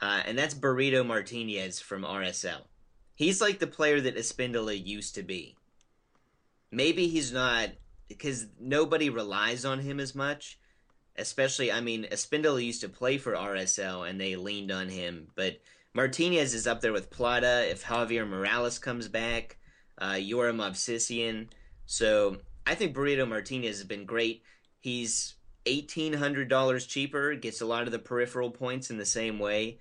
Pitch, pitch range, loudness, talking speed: 120 Hz, 110-135 Hz, -30 LUFS, 160 wpm